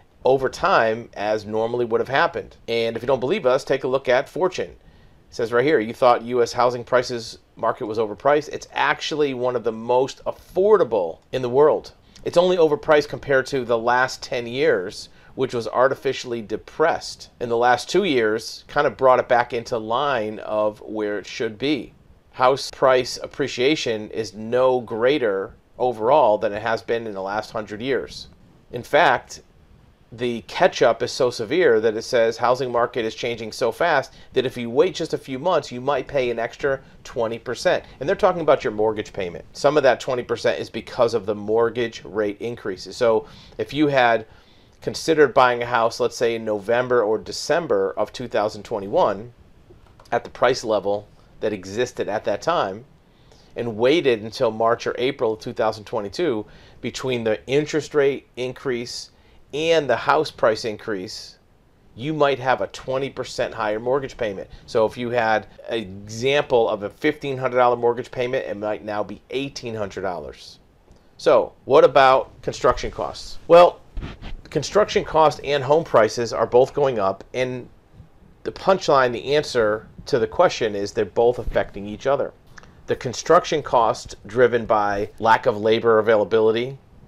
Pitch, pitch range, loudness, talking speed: 120 Hz, 110-135 Hz, -21 LUFS, 165 wpm